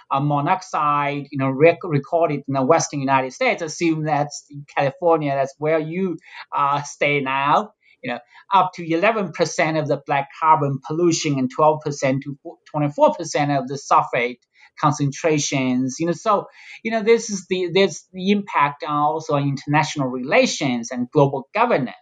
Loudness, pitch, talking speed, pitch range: -20 LUFS, 150 Hz, 160 wpm, 140-170 Hz